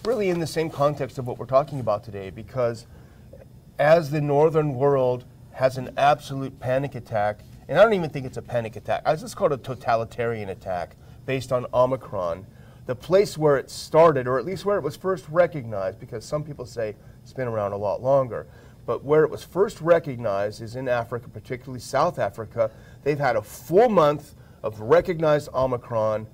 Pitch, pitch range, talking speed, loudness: 130 Hz, 120-150 Hz, 190 wpm, -24 LUFS